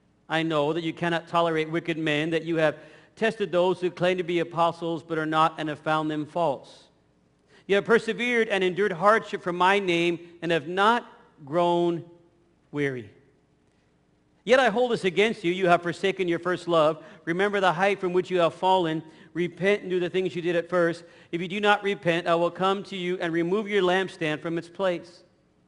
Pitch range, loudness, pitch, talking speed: 165-190 Hz, -25 LUFS, 175 Hz, 200 wpm